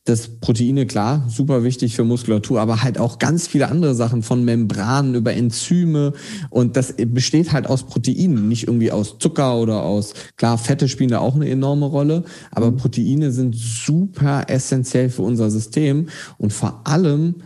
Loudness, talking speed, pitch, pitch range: -18 LUFS, 170 wpm, 130 Hz, 115-145 Hz